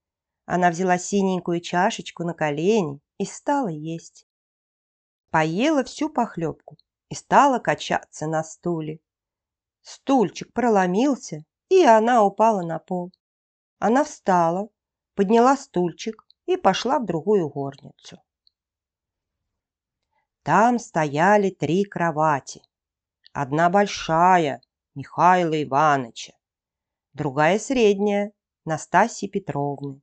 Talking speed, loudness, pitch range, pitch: 90 wpm, -21 LUFS, 150-210 Hz, 175 Hz